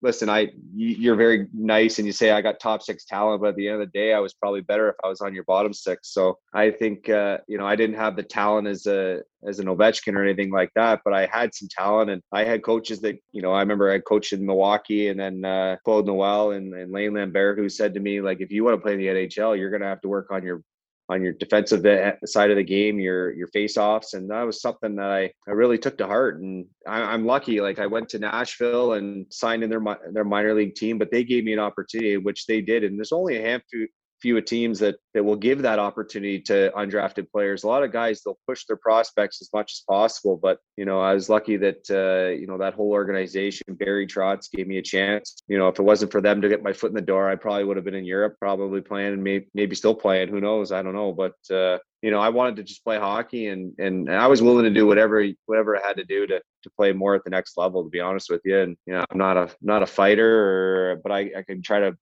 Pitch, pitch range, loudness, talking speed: 100 Hz, 95-110 Hz, -23 LUFS, 270 wpm